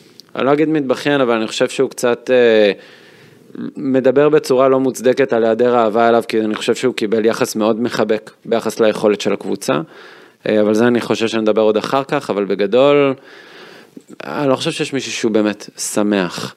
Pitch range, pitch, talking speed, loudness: 110-130 Hz, 115 Hz, 170 wpm, -15 LUFS